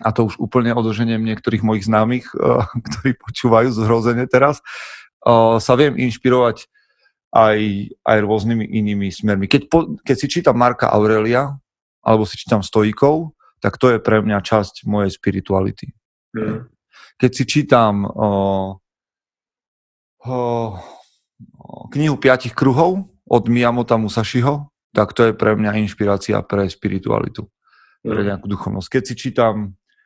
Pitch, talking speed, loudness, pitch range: 115 Hz, 130 wpm, -17 LUFS, 105-125 Hz